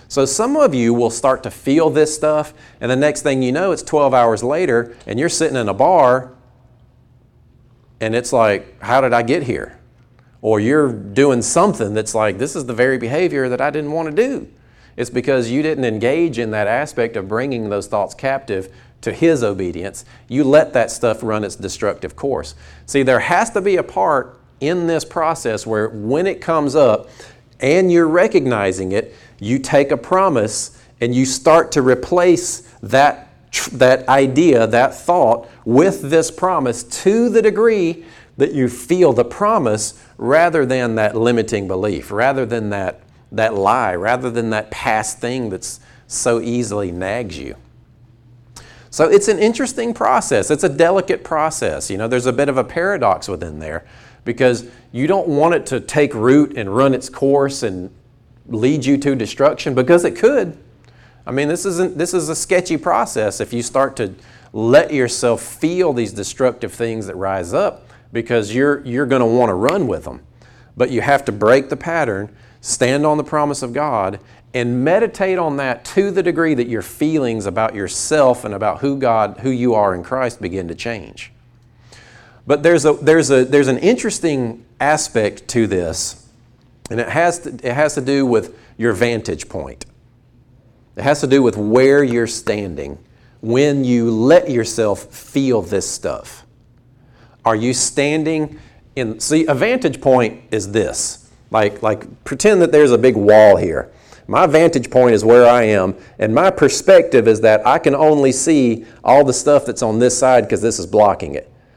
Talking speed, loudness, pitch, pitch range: 180 wpm, -16 LUFS, 125 Hz, 115-145 Hz